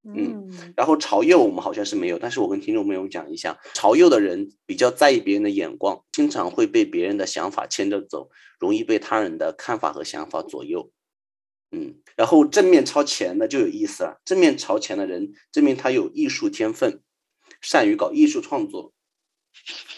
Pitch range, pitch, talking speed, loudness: 295-345 Hz, 315 Hz, 290 characters per minute, -21 LUFS